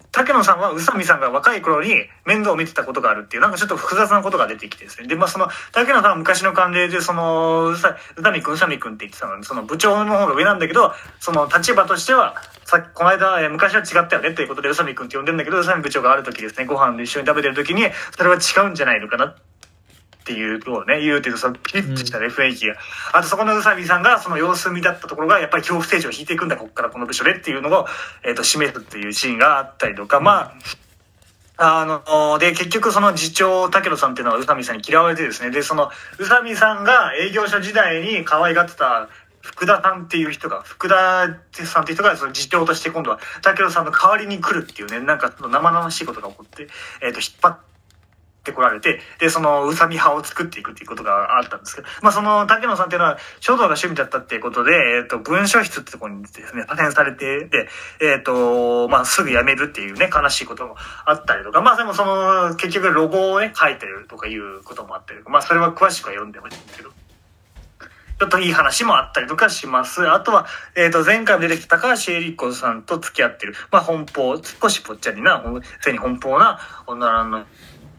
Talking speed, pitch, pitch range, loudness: 465 characters per minute, 170 Hz, 130-190 Hz, -17 LUFS